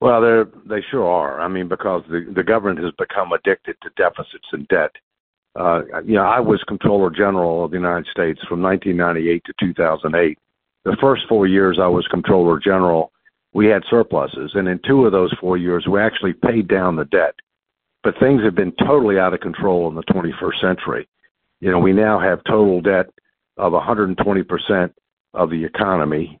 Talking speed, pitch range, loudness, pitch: 180 wpm, 85-105 Hz, -18 LUFS, 95 Hz